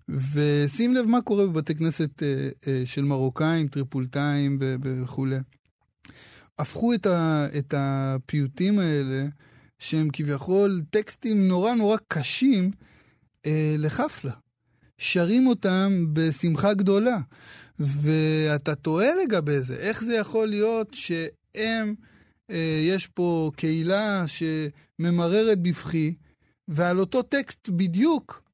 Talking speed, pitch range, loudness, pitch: 105 wpm, 140-200 Hz, -25 LUFS, 160 Hz